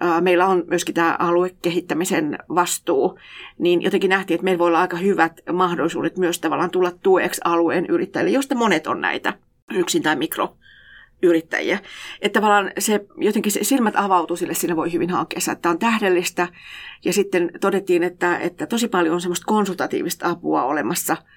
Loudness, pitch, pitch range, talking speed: -20 LUFS, 180 Hz, 175-200 Hz, 155 wpm